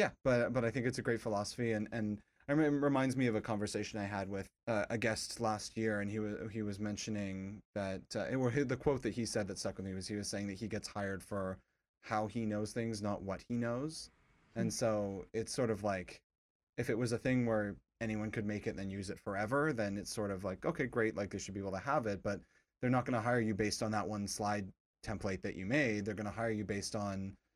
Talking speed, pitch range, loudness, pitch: 260 wpm, 100-115 Hz, -38 LUFS, 105 Hz